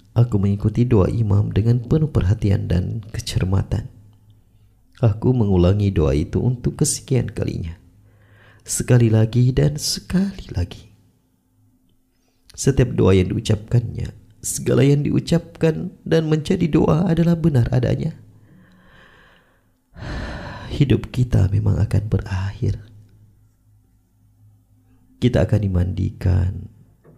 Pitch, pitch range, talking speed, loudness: 110 Hz, 100-125 Hz, 95 wpm, -20 LUFS